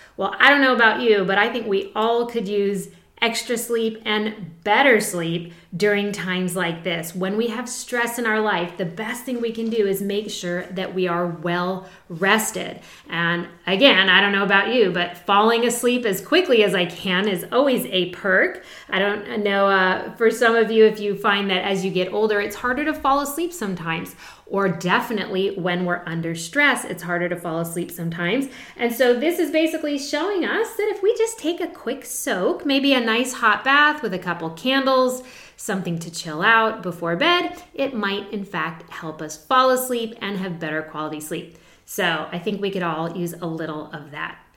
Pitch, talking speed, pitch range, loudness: 205 Hz, 200 wpm, 180-240 Hz, -21 LUFS